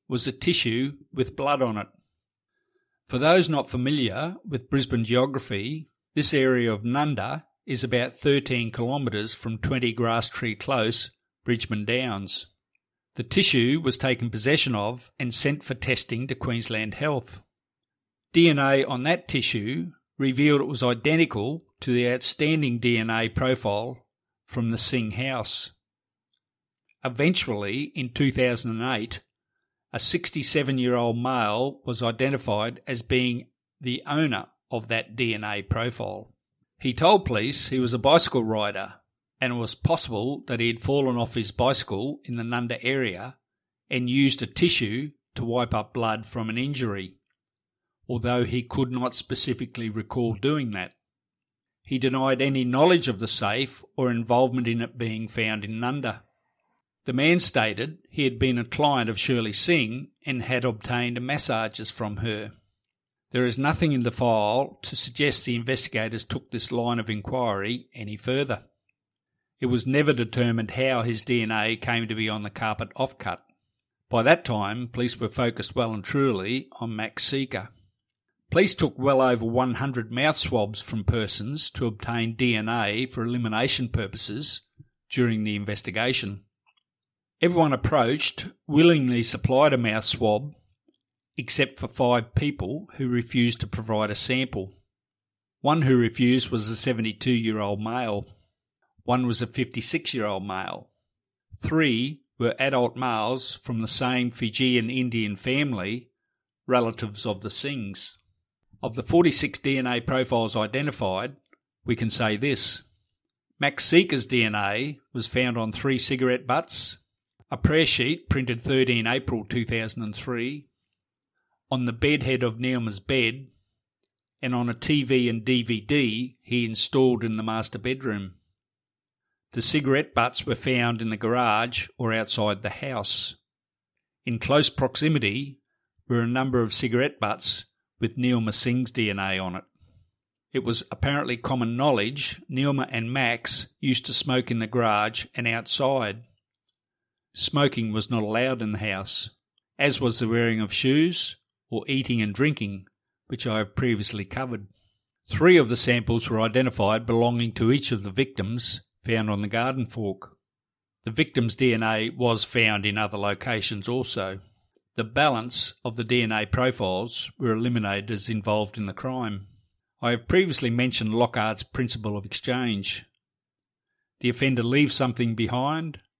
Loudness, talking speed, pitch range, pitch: -25 LUFS, 145 wpm, 110-130 Hz, 120 Hz